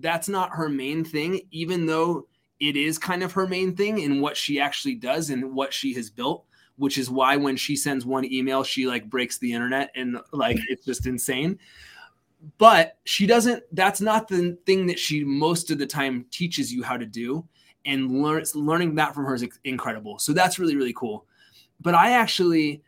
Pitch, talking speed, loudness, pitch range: 150 Hz, 200 wpm, -24 LUFS, 130-175 Hz